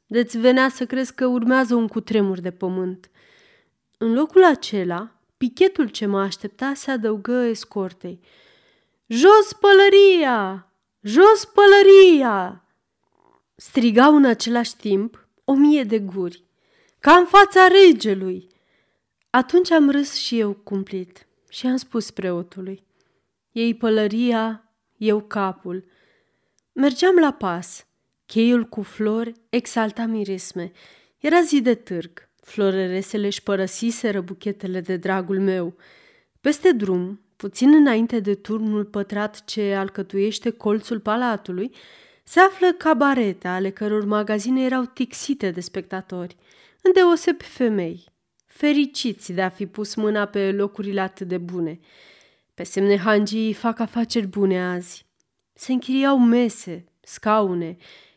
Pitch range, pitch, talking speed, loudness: 195-260 Hz, 220 Hz, 120 wpm, -19 LUFS